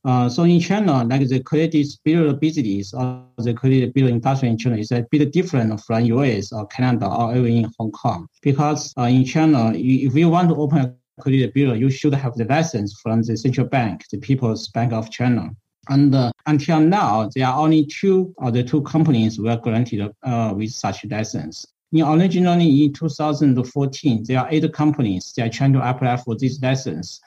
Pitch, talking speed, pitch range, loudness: 130 Hz, 205 wpm, 115-150 Hz, -19 LUFS